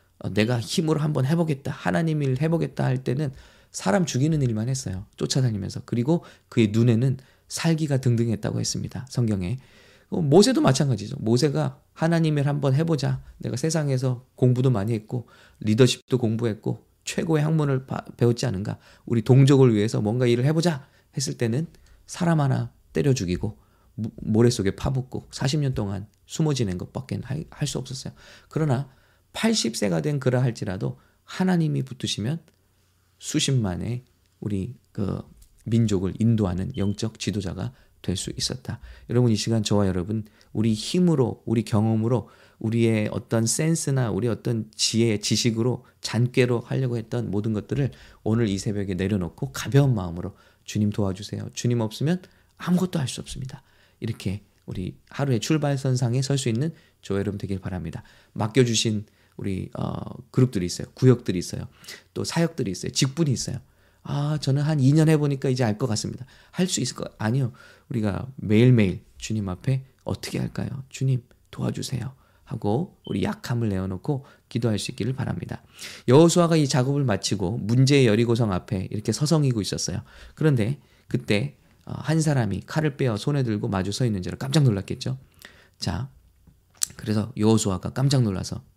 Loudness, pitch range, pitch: -24 LUFS, 105-140 Hz, 120 Hz